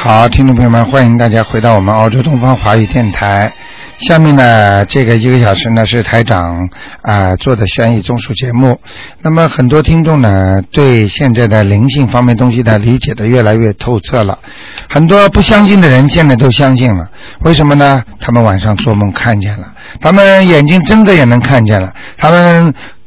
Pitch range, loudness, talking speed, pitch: 110-140 Hz, -8 LUFS, 290 characters per minute, 120 Hz